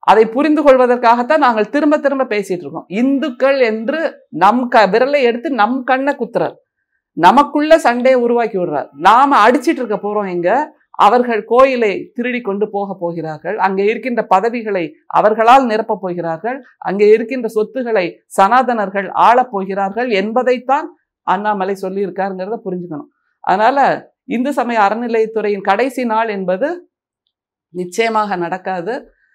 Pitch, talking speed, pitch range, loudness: 230 Hz, 115 wpm, 195-260 Hz, -14 LUFS